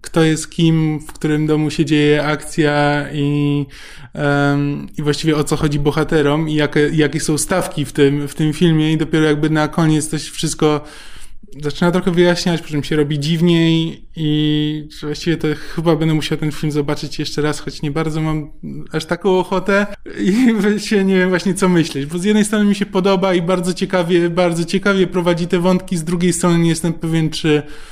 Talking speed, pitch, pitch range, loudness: 190 wpm, 155 Hz, 150-180 Hz, -16 LUFS